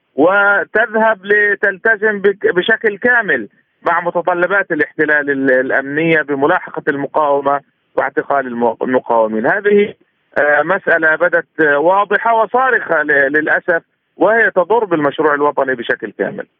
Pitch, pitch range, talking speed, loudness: 170 Hz, 145-205 Hz, 85 wpm, -14 LUFS